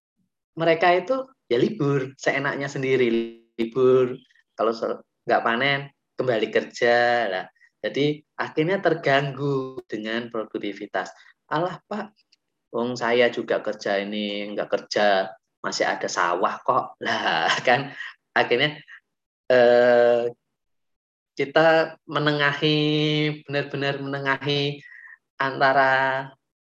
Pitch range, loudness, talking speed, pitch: 120-150 Hz, -23 LUFS, 90 wpm, 135 Hz